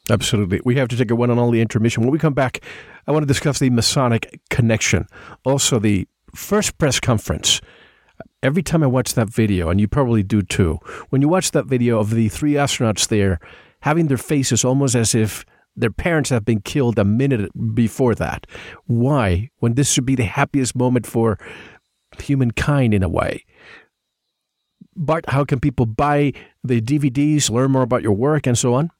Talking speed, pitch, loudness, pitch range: 190 wpm, 125 Hz, -18 LUFS, 115-145 Hz